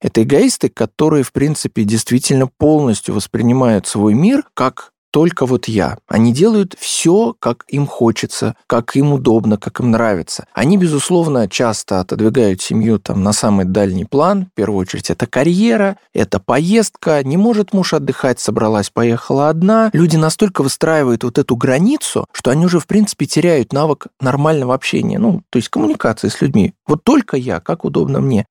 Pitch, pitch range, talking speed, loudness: 135 Hz, 115-170 Hz, 160 wpm, -14 LUFS